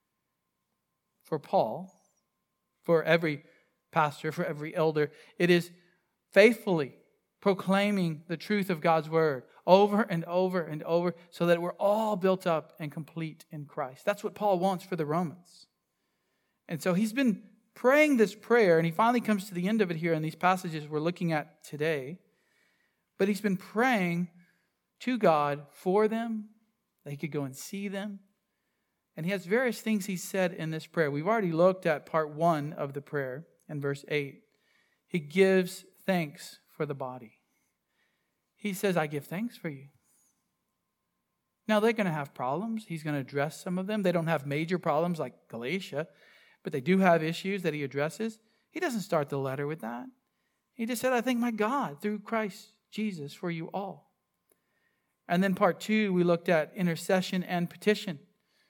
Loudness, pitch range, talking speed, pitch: -29 LUFS, 160-205 Hz, 175 wpm, 180 Hz